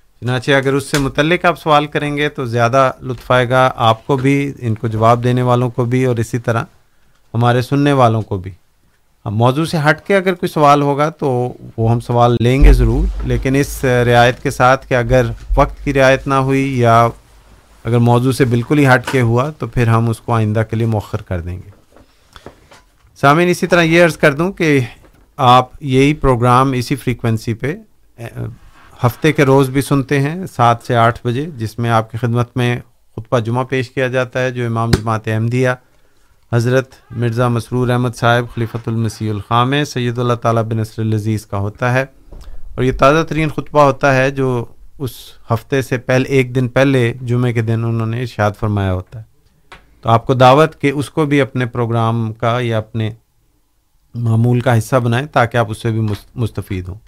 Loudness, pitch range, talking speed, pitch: -15 LUFS, 115-135 Hz, 195 wpm, 125 Hz